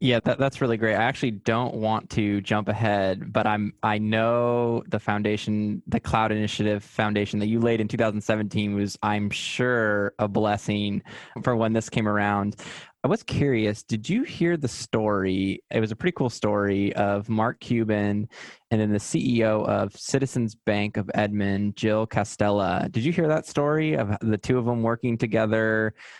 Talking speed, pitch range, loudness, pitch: 175 wpm, 105-115 Hz, -25 LUFS, 110 Hz